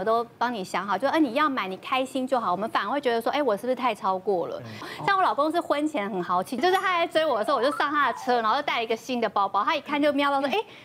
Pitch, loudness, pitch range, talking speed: 260 Hz, -25 LUFS, 220-300 Hz, 415 characters per minute